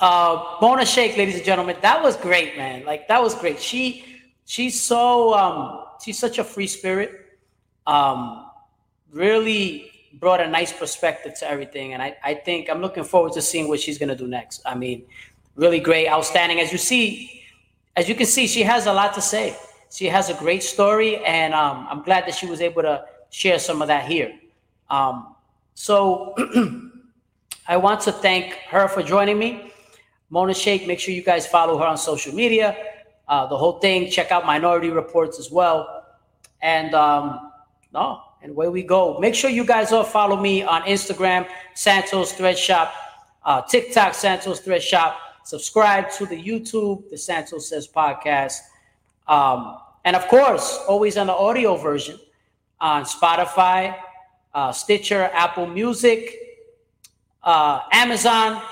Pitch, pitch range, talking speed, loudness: 185 Hz, 165-215 Hz, 165 wpm, -19 LUFS